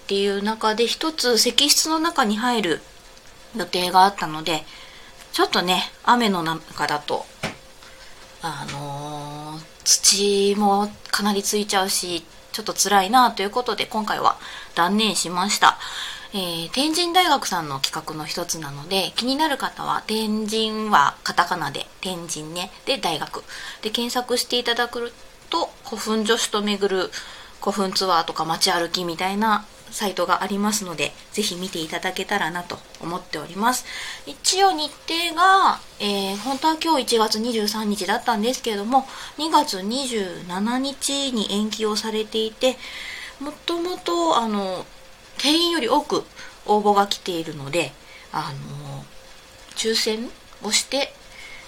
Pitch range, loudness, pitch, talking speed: 180-245 Hz, -22 LUFS, 210 Hz, 250 characters per minute